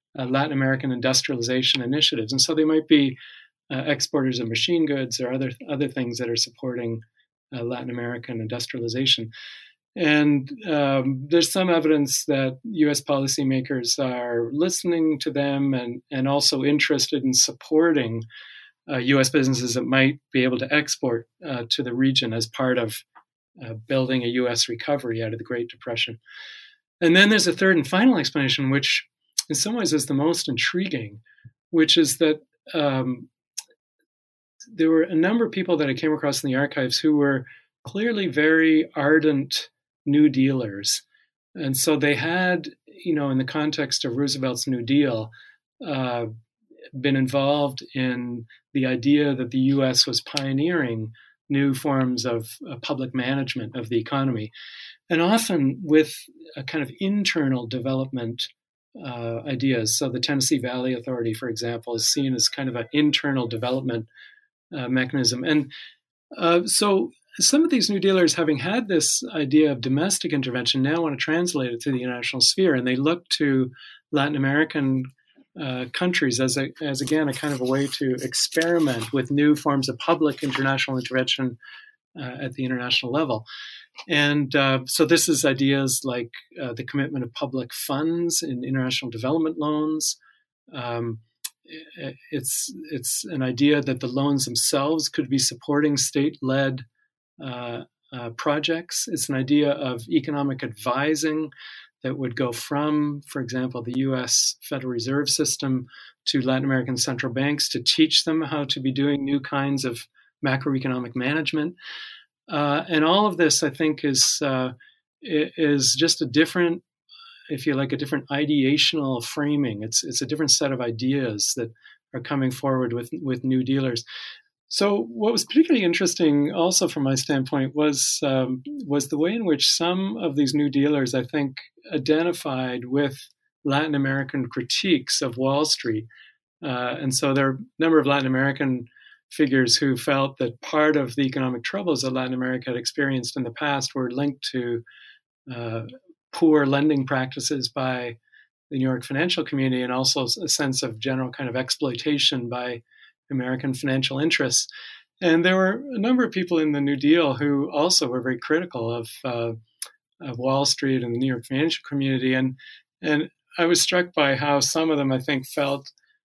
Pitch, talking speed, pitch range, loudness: 140 Hz, 165 wpm, 130-155 Hz, -22 LUFS